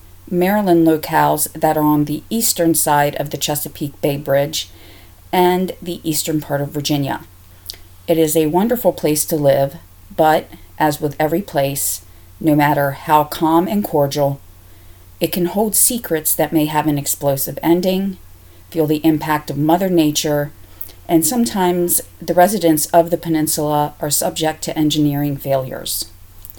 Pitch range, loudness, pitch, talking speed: 140-170 Hz, -17 LUFS, 150 Hz, 145 wpm